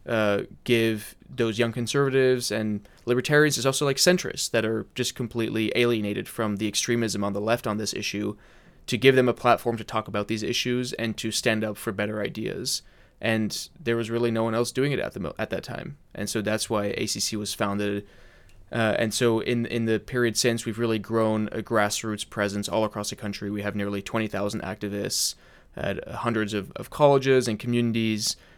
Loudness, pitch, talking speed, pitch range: -26 LUFS, 110 Hz, 200 wpm, 105-120 Hz